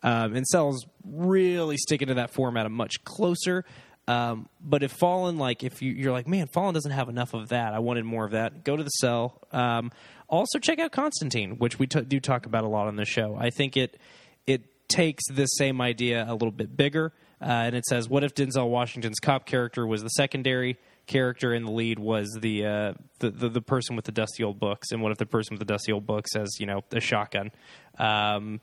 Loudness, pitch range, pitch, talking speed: -27 LUFS, 110-140 Hz, 120 Hz, 230 wpm